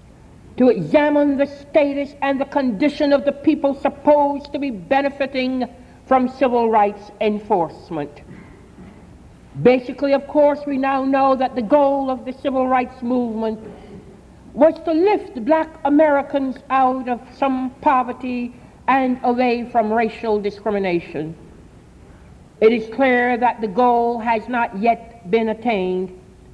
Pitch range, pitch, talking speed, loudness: 230-280 Hz, 255 Hz, 130 wpm, -19 LUFS